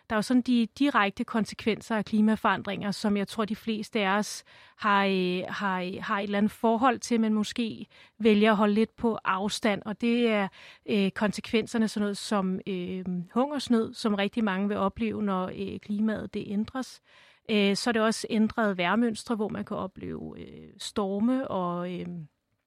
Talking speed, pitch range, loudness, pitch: 180 wpm, 195-225 Hz, -28 LUFS, 210 Hz